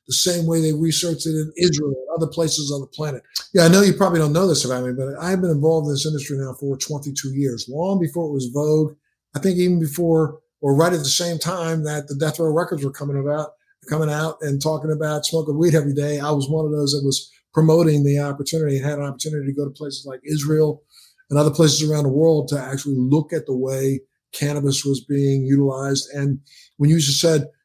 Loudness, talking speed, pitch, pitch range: -20 LUFS, 235 wpm, 150 Hz, 140-160 Hz